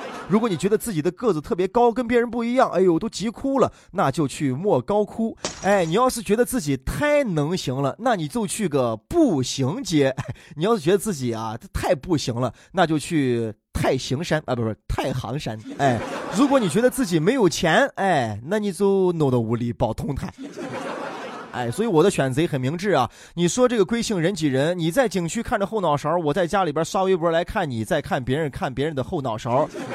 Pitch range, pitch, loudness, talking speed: 135-215 Hz, 175 Hz, -22 LUFS, 300 characters per minute